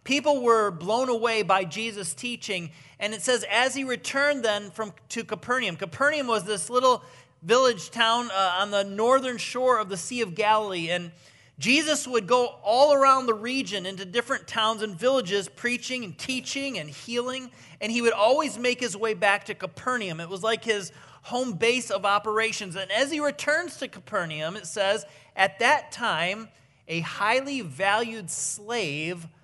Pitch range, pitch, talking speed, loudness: 195-250 Hz, 220 Hz, 170 wpm, -25 LUFS